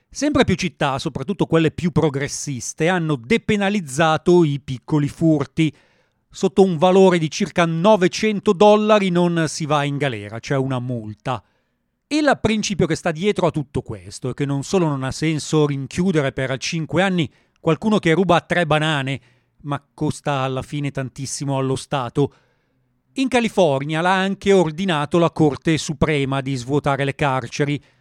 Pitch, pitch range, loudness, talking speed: 155 Hz, 135-180 Hz, -19 LUFS, 155 wpm